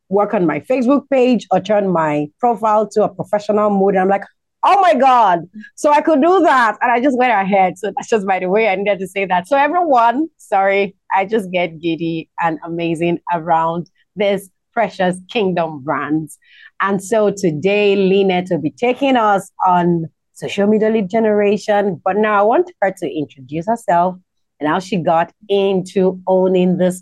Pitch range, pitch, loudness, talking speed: 175-220 Hz, 195 Hz, -16 LUFS, 180 wpm